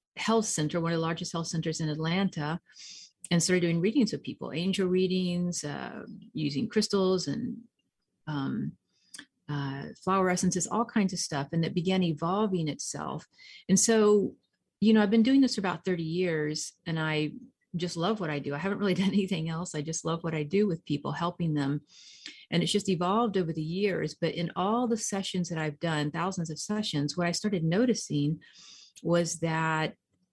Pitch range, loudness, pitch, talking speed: 160-205 Hz, -29 LUFS, 180 Hz, 185 wpm